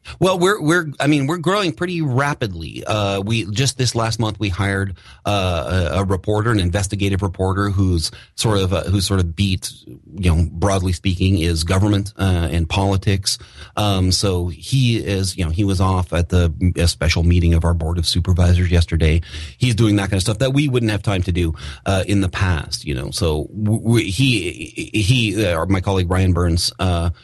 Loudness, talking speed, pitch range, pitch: -18 LUFS, 200 wpm, 90-110 Hz, 95 Hz